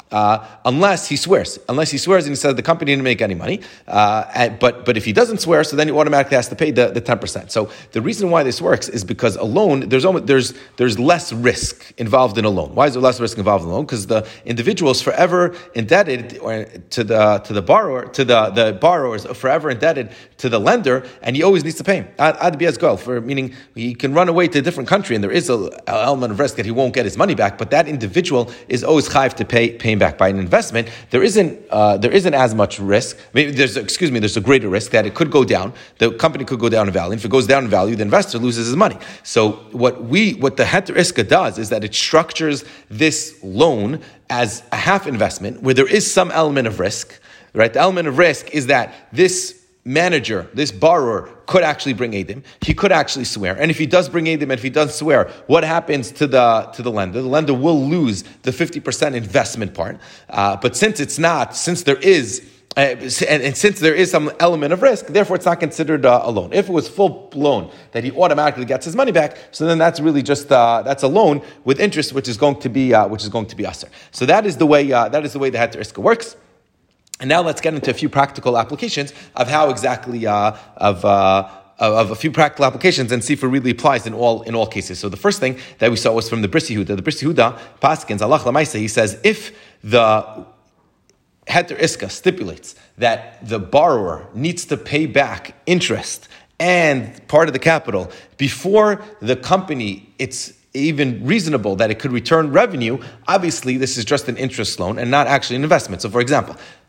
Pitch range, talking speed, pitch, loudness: 115-155 Hz, 230 wpm, 135 Hz, -17 LUFS